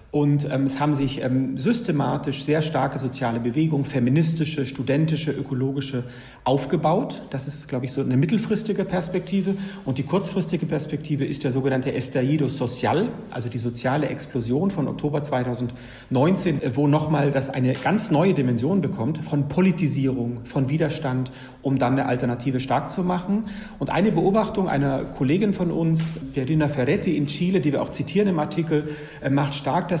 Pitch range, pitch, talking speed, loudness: 130-165 Hz, 145 Hz, 150 wpm, -23 LUFS